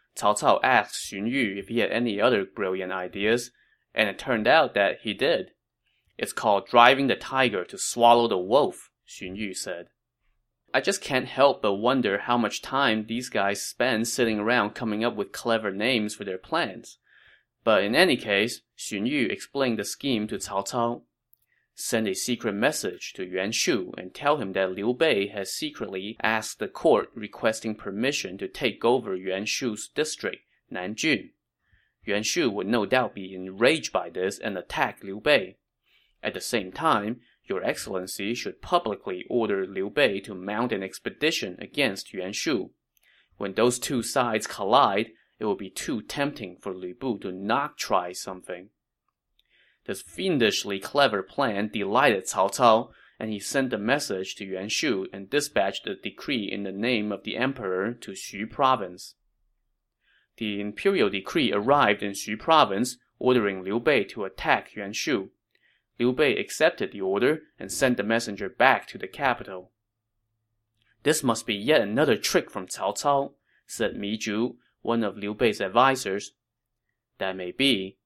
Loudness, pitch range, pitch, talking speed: -26 LUFS, 100-125 Hz, 110 Hz, 165 wpm